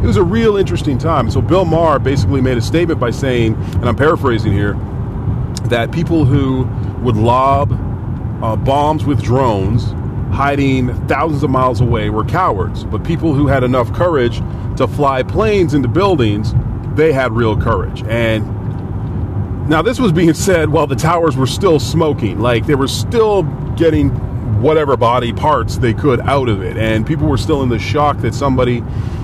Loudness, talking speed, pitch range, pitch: -14 LUFS, 175 wpm, 110-140 Hz, 120 Hz